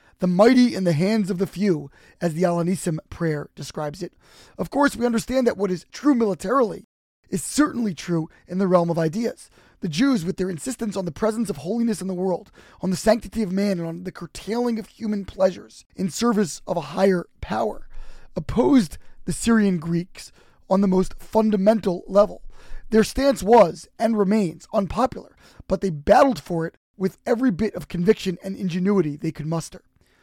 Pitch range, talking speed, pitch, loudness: 175-220 Hz, 185 wpm, 195 Hz, -22 LUFS